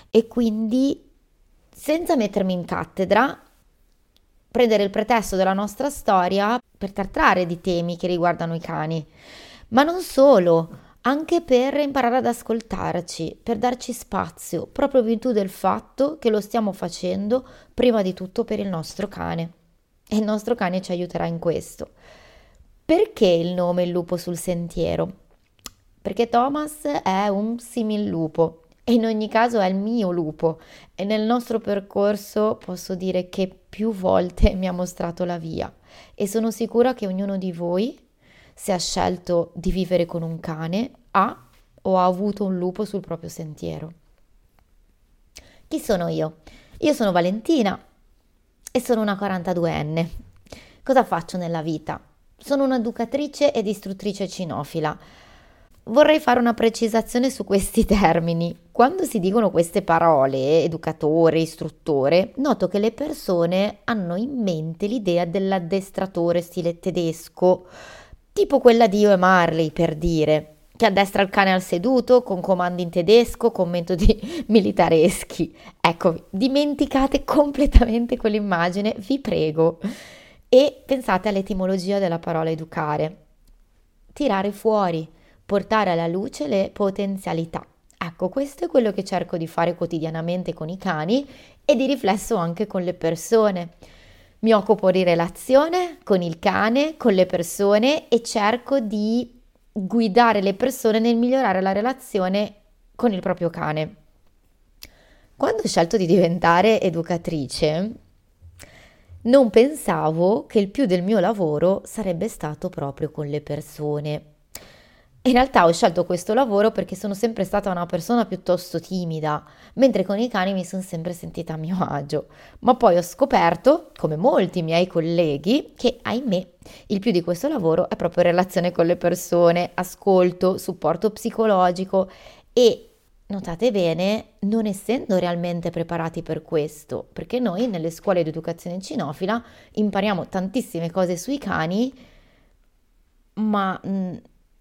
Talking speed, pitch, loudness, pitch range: 135 wpm, 190 Hz, -21 LUFS, 170-230 Hz